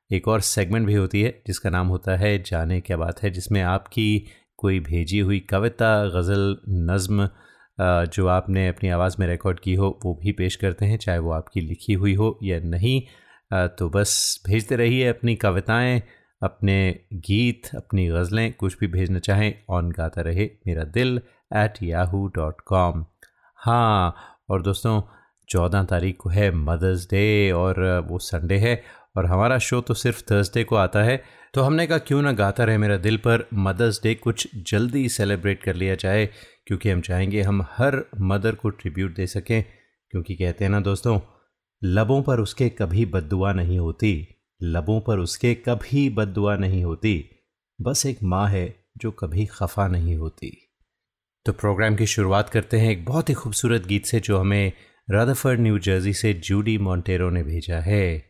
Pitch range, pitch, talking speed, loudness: 95-110 Hz, 100 Hz, 170 wpm, -23 LUFS